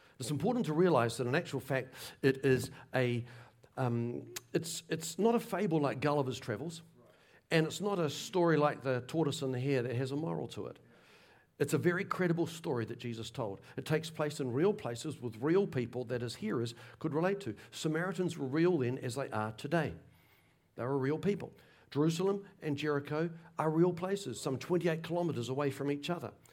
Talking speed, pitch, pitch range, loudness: 190 wpm, 145 Hz, 125-165 Hz, -35 LUFS